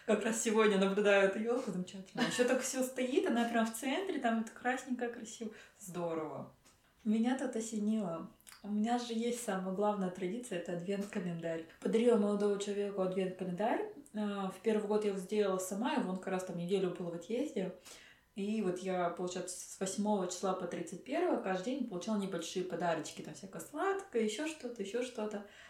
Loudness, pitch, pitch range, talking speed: -36 LUFS, 210 Hz, 185-235 Hz, 175 wpm